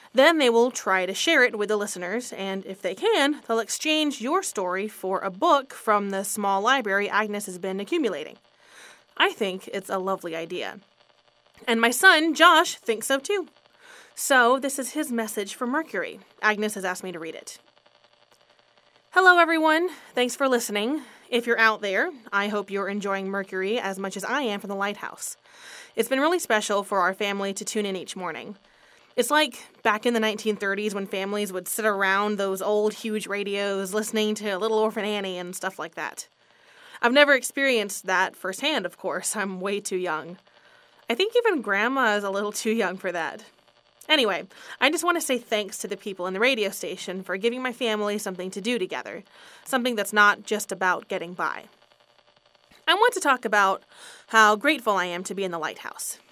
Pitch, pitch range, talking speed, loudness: 210 Hz, 195-255 Hz, 190 wpm, -24 LUFS